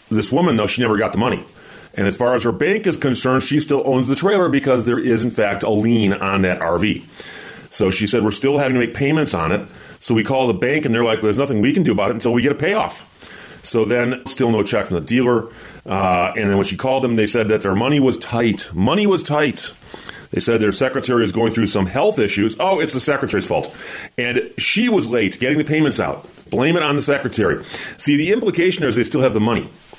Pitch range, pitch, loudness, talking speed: 110-140 Hz, 120 Hz, -18 LUFS, 250 wpm